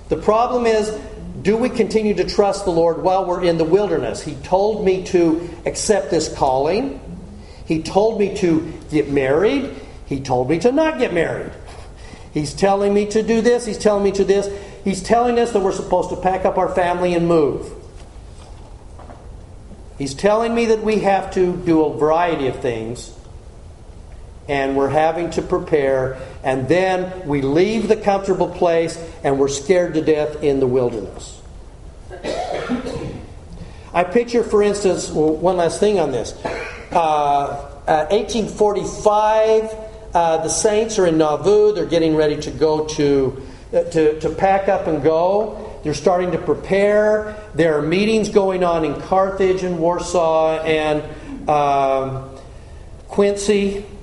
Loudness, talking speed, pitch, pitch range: -18 LUFS, 155 wpm, 175 Hz, 150-200 Hz